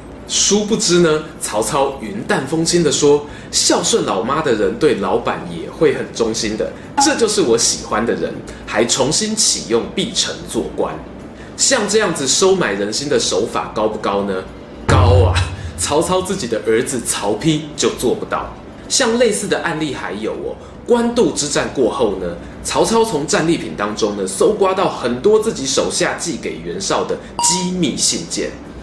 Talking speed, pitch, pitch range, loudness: 245 characters per minute, 185 Hz, 145-225 Hz, -16 LUFS